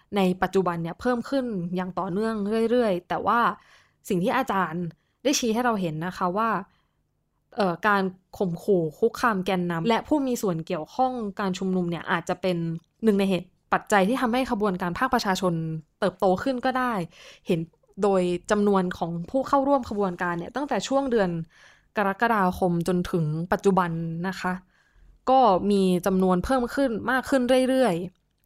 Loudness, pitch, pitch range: -25 LUFS, 195 Hz, 180-235 Hz